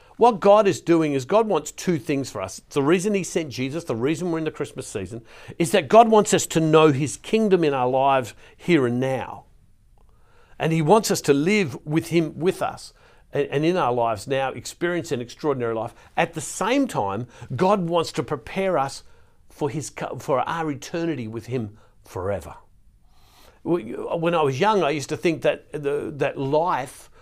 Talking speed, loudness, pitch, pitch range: 190 wpm, -22 LUFS, 155 Hz, 130-175 Hz